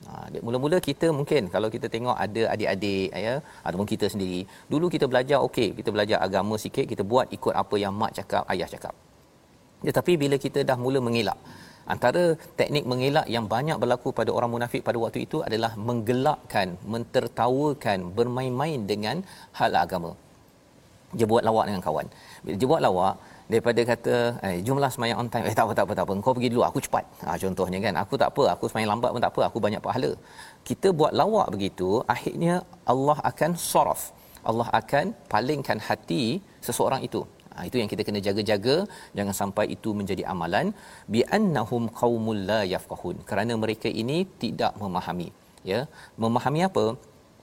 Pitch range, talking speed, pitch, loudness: 105-135 Hz, 170 wpm, 115 Hz, -26 LUFS